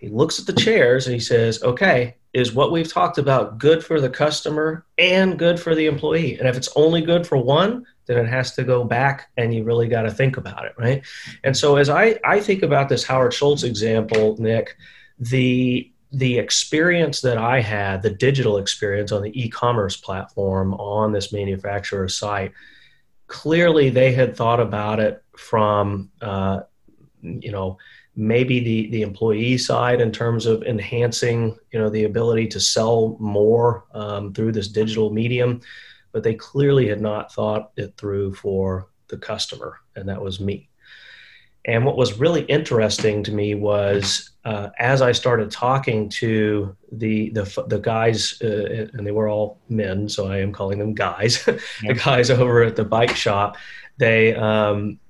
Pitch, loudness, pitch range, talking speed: 115 Hz, -20 LUFS, 105-130 Hz, 175 wpm